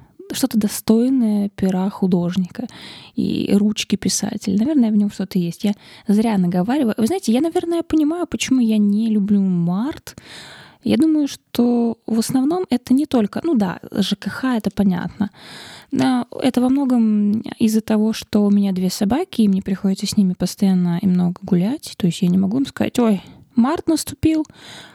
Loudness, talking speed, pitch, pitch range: -19 LUFS, 165 wpm, 215 Hz, 200-255 Hz